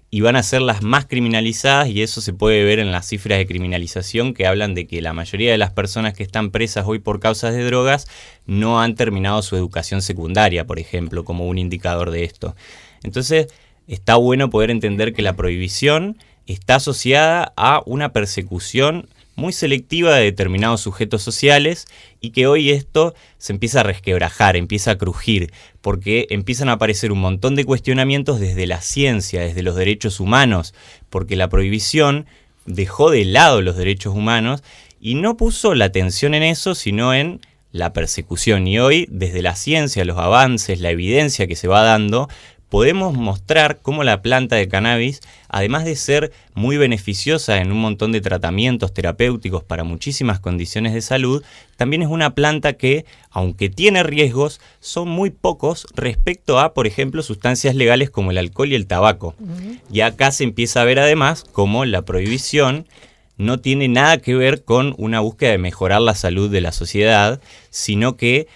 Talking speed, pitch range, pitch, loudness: 175 wpm, 95-135 Hz, 110 Hz, -17 LUFS